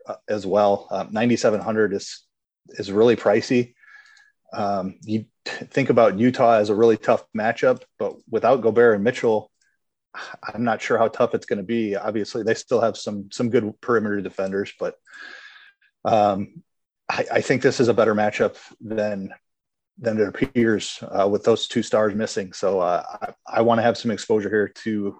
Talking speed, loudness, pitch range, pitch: 175 wpm, -21 LUFS, 105-130 Hz, 110 Hz